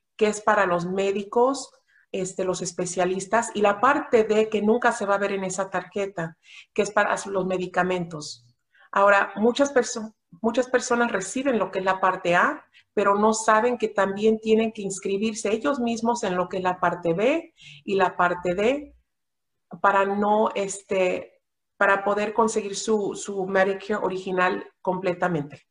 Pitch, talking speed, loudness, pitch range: 200 Hz, 165 wpm, -24 LUFS, 185-220 Hz